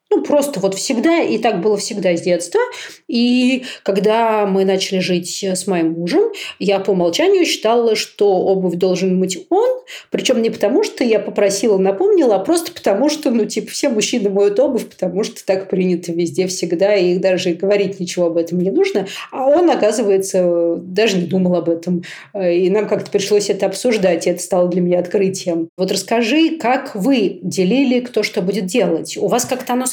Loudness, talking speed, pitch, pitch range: -16 LUFS, 180 wpm, 205 Hz, 185-250 Hz